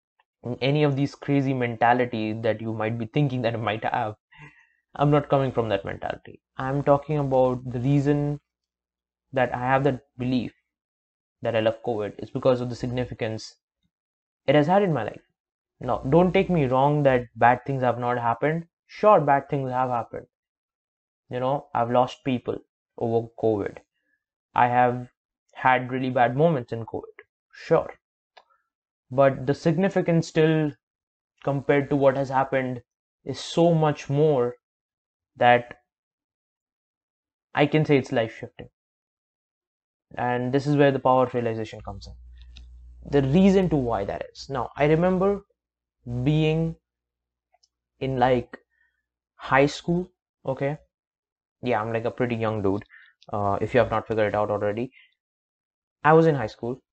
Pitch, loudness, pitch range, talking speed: 125 Hz, -24 LUFS, 115-145 Hz, 150 wpm